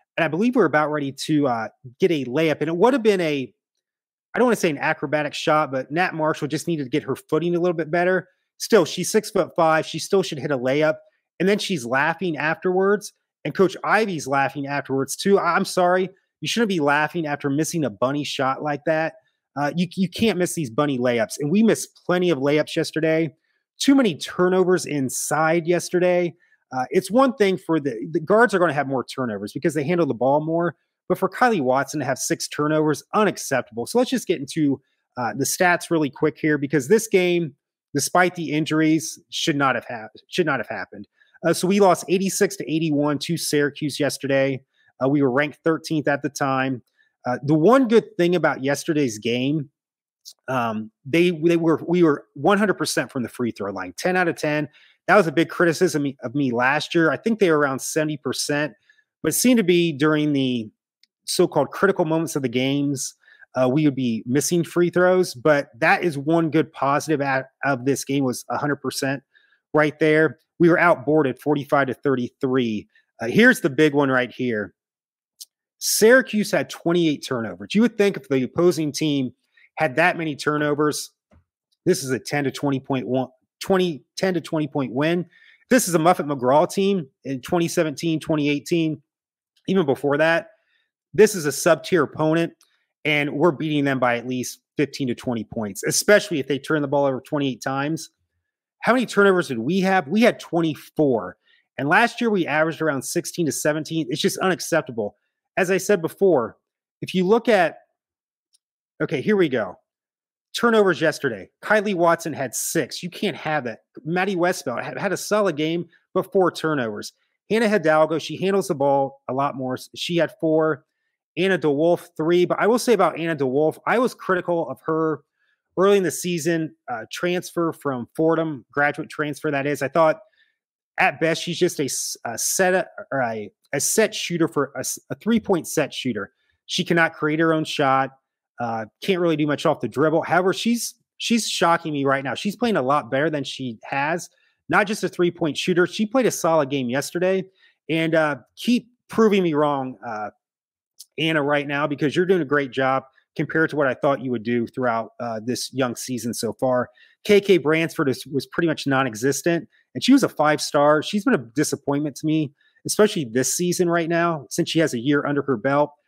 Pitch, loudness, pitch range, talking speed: 155 Hz, -21 LUFS, 140-180 Hz, 190 wpm